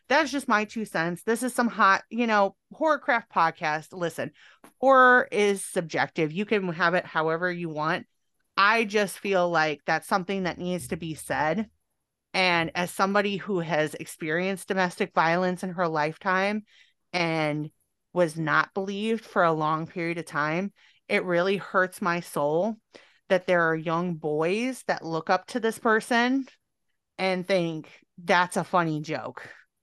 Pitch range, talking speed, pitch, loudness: 165-205 Hz, 155 wpm, 180 Hz, -26 LUFS